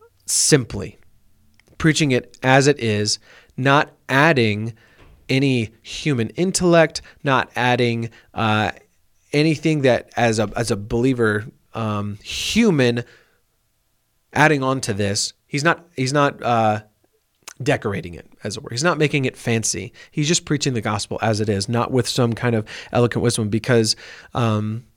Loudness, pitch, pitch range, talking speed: -20 LUFS, 120 Hz, 110-140 Hz, 140 wpm